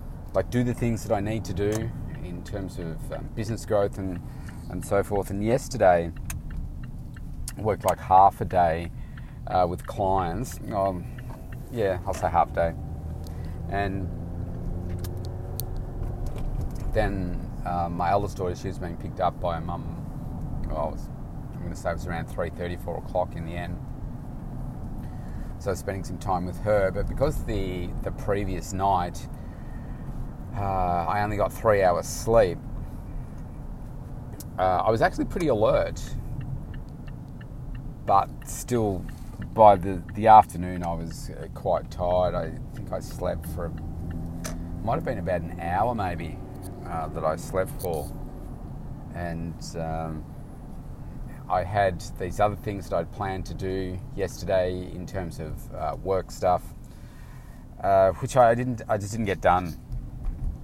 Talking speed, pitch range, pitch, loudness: 145 wpm, 85-105 Hz, 95 Hz, -27 LUFS